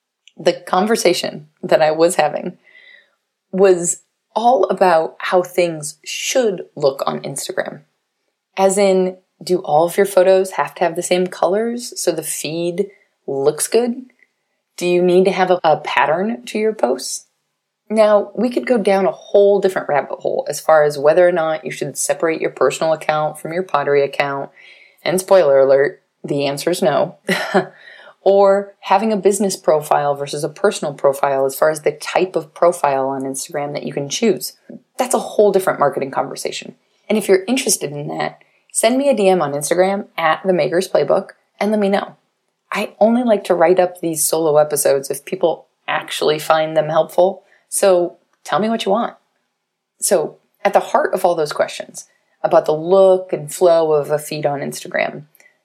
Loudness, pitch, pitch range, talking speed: -17 LUFS, 180 Hz, 155-200 Hz, 175 wpm